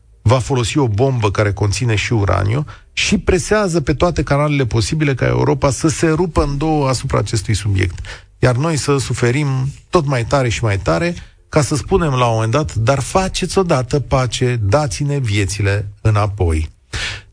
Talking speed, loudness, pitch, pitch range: 165 wpm, -16 LUFS, 125 Hz, 105-150 Hz